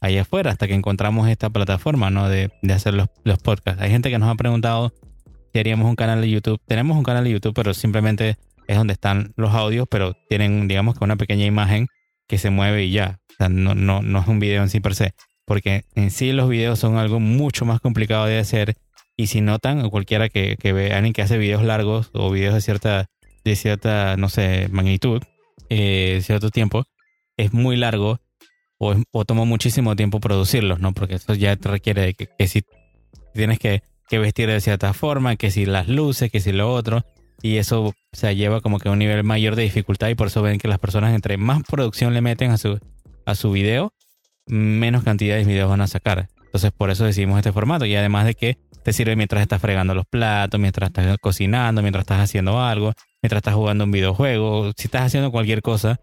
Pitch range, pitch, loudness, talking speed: 100-115 Hz, 105 Hz, -20 LUFS, 220 wpm